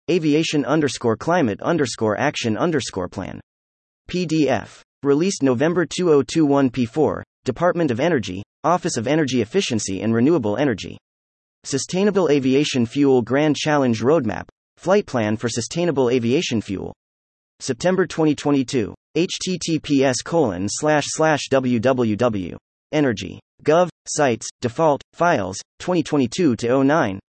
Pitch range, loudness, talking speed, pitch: 110-155 Hz, -20 LUFS, 100 wpm, 135 Hz